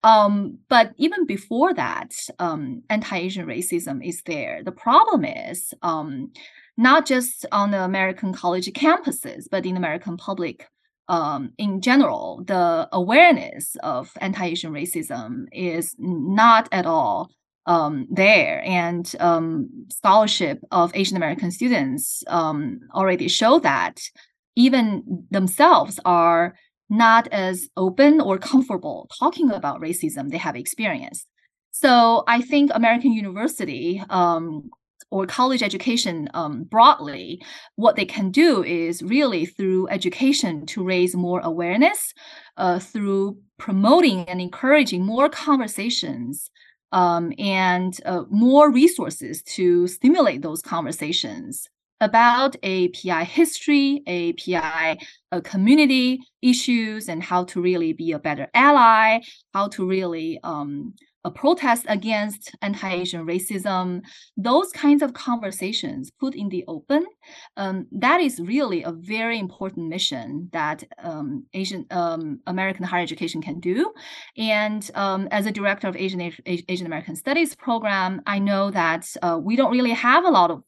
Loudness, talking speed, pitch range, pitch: -20 LUFS, 130 wpm, 180-270 Hz, 205 Hz